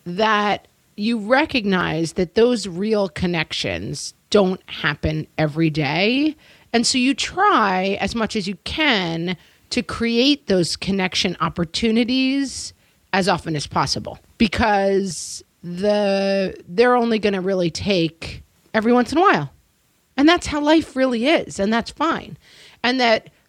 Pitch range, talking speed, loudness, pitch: 185-245 Hz, 135 wpm, -20 LUFS, 205 Hz